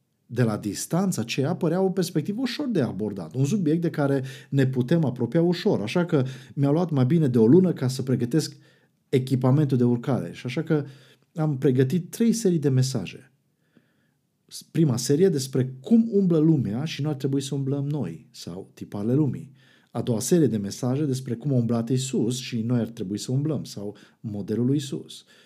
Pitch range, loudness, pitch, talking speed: 125-160 Hz, -24 LUFS, 140 Hz, 185 wpm